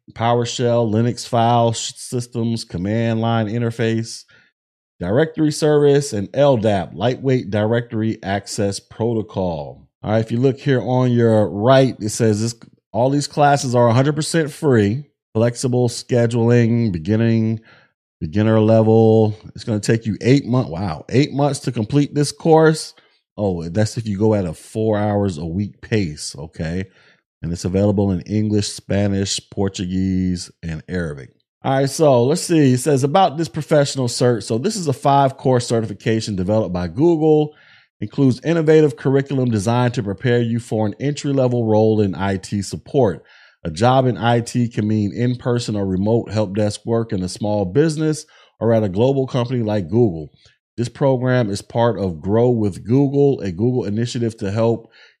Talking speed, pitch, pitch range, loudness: 160 wpm, 115 Hz, 105-130 Hz, -18 LUFS